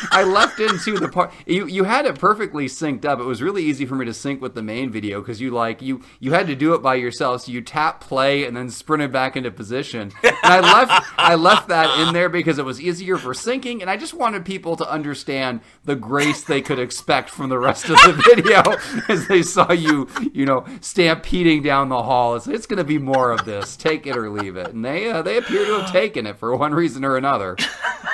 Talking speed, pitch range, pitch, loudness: 245 wpm, 130-180 Hz, 145 Hz, -18 LUFS